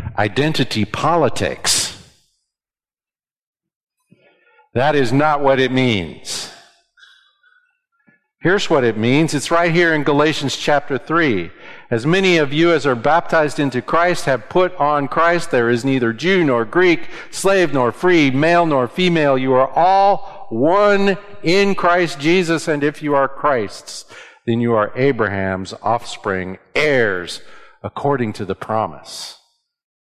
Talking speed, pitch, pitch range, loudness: 130 wpm, 155 Hz, 130-180 Hz, -16 LUFS